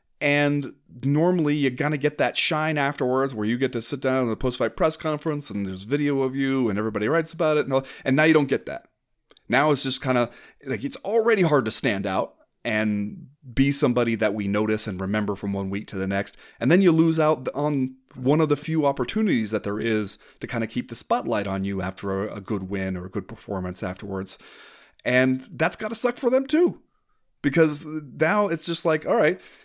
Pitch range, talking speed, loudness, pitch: 105-155 Hz, 225 wpm, -24 LUFS, 130 Hz